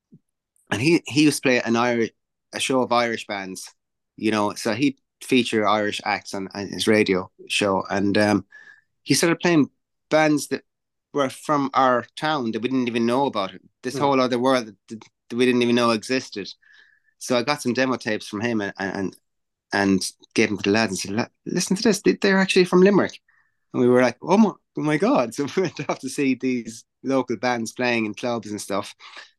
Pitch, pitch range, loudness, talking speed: 125 Hz, 110-145 Hz, -22 LUFS, 205 wpm